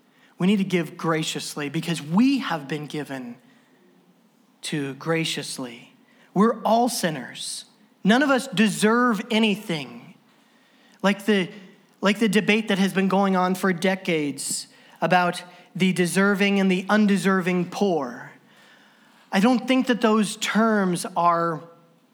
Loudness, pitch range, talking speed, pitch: -22 LUFS, 170-225 Hz, 125 wpm, 195 Hz